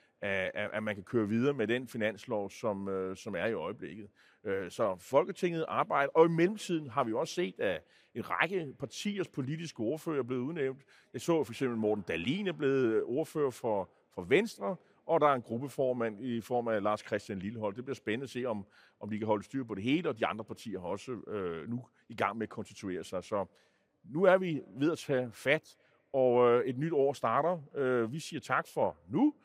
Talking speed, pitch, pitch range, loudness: 200 wpm, 130 Hz, 110-155 Hz, -33 LUFS